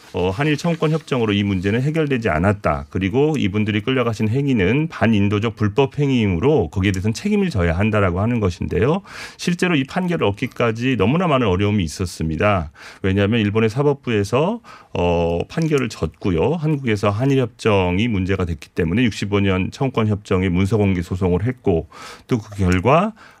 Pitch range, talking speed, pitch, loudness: 95-135 Hz, 375 characters per minute, 110 Hz, -19 LUFS